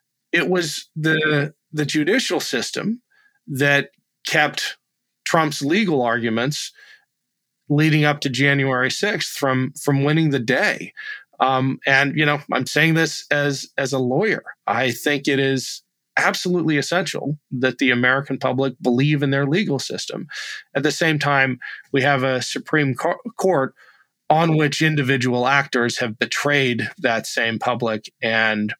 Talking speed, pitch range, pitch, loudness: 140 wpm, 130-155 Hz, 140 Hz, -20 LUFS